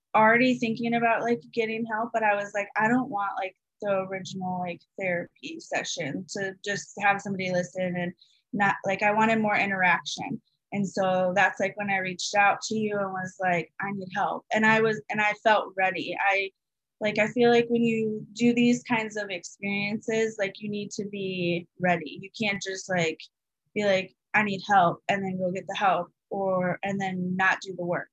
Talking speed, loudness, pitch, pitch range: 200 wpm, -26 LUFS, 200 Hz, 185-220 Hz